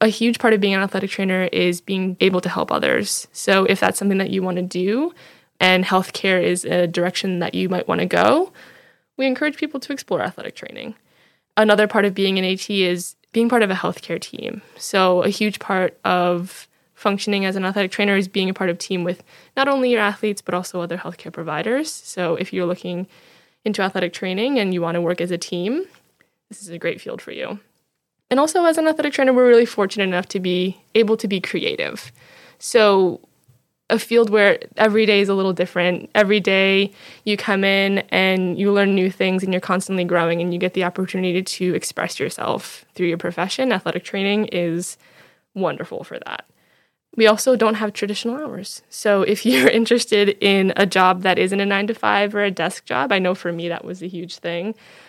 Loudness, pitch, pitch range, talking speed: -19 LUFS, 195 Hz, 180-215 Hz, 210 wpm